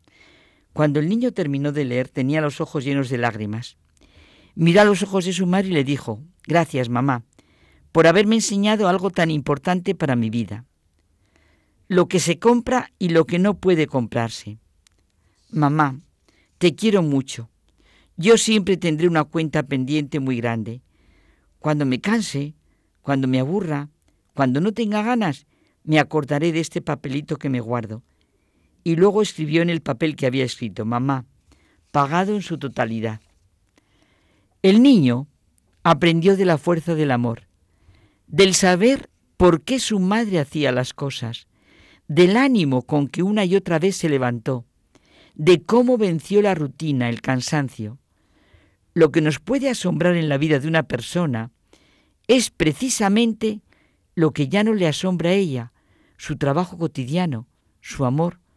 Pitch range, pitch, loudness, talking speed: 125-180 Hz, 150 Hz, -20 LUFS, 150 wpm